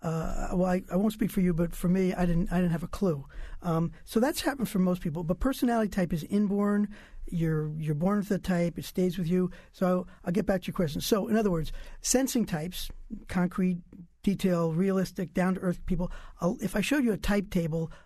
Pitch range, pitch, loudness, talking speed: 175-205 Hz, 185 Hz, -29 LUFS, 225 wpm